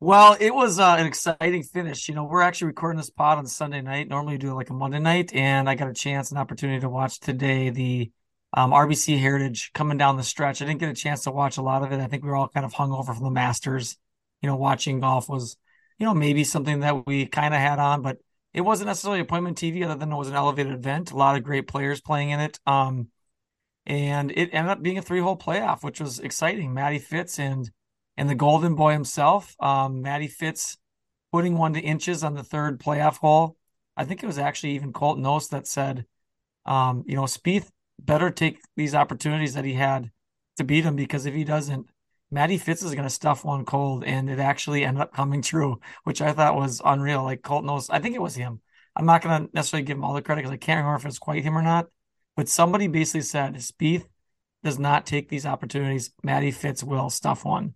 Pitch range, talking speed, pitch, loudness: 135-155 Hz, 235 wpm, 145 Hz, -24 LUFS